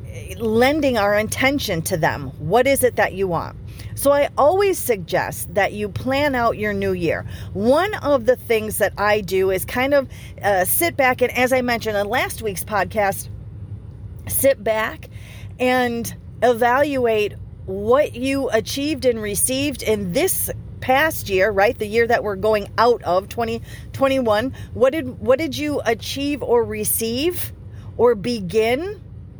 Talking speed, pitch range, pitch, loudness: 155 wpm, 190-260 Hz, 225 Hz, -19 LUFS